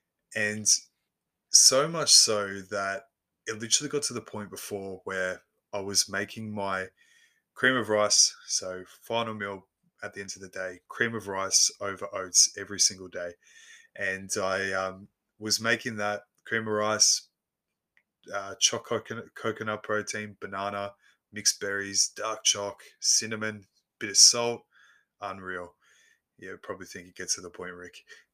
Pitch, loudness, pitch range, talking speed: 100 Hz, -25 LUFS, 95-110 Hz, 145 wpm